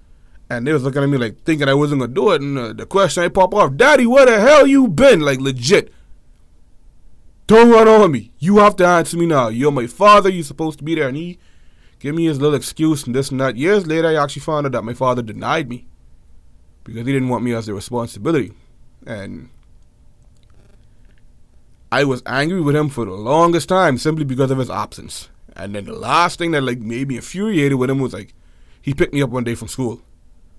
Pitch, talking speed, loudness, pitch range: 140 Hz, 225 wpm, -15 LUFS, 120-165 Hz